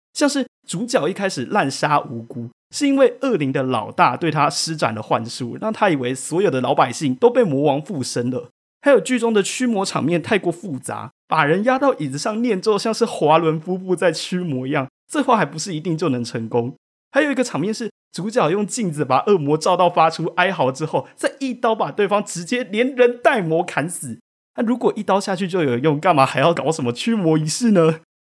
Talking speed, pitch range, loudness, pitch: 310 characters per minute, 140-225 Hz, -19 LUFS, 175 Hz